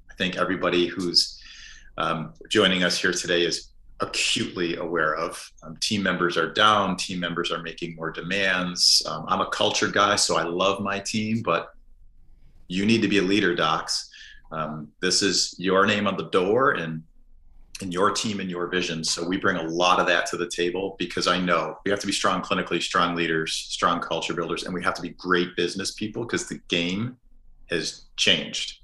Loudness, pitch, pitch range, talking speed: -24 LUFS, 90 Hz, 85-100 Hz, 195 wpm